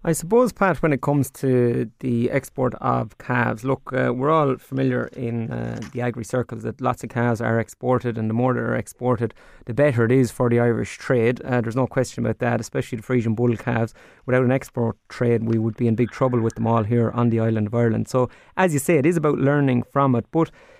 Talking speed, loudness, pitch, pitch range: 235 wpm, -22 LUFS, 120 Hz, 115-130 Hz